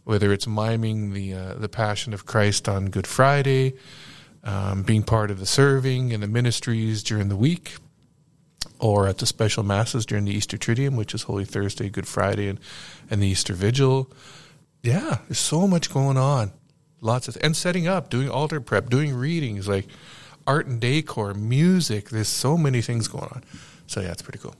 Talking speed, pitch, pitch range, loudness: 185 wpm, 120 Hz, 105-140 Hz, -23 LUFS